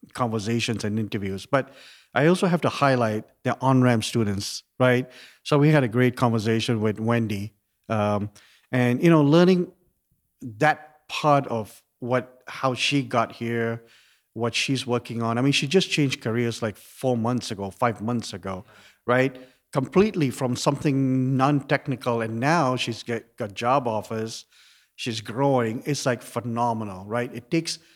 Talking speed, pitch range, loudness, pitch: 155 wpm, 115-140 Hz, -24 LUFS, 120 Hz